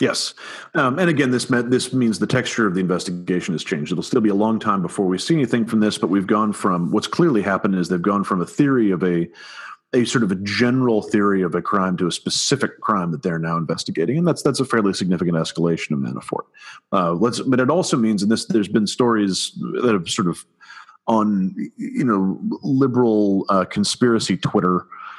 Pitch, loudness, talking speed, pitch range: 105 Hz, -20 LUFS, 210 wpm, 90-120 Hz